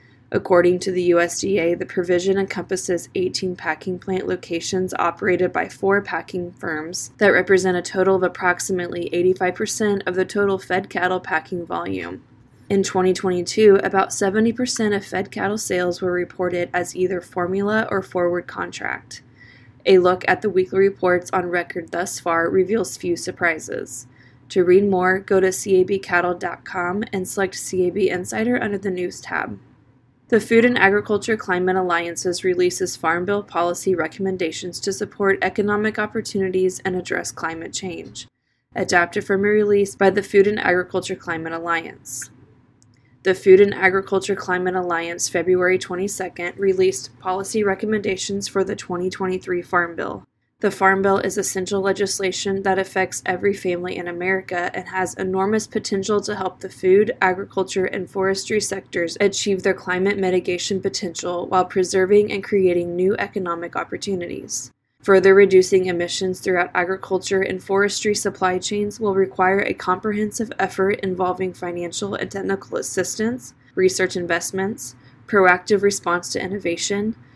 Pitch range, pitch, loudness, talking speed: 175-195 Hz, 185 Hz, -20 LUFS, 140 wpm